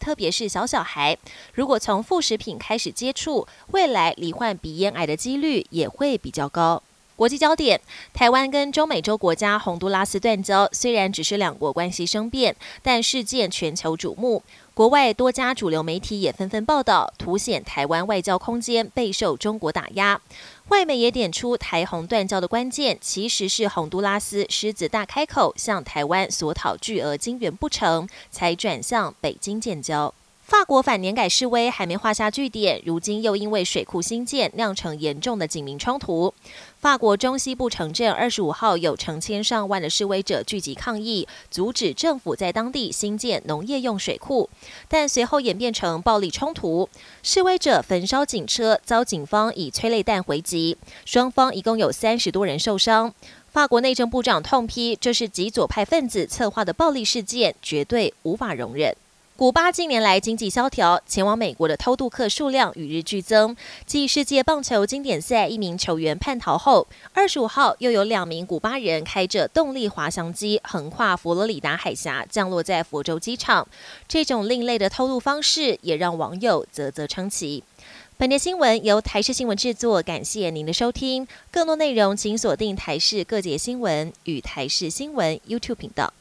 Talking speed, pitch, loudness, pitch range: 280 characters per minute, 215 Hz, -22 LUFS, 180-245 Hz